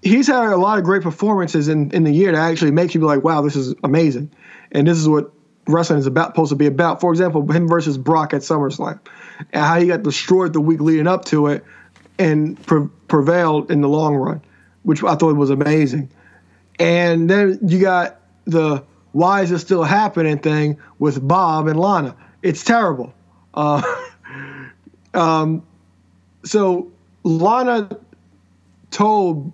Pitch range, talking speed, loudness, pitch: 145-180 Hz, 170 wpm, -17 LUFS, 160 Hz